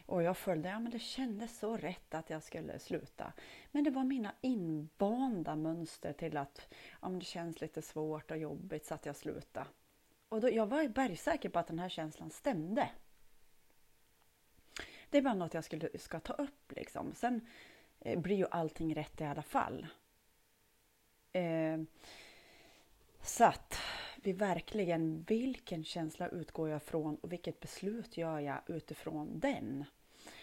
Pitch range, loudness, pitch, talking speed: 155-220 Hz, -39 LUFS, 170 Hz, 160 wpm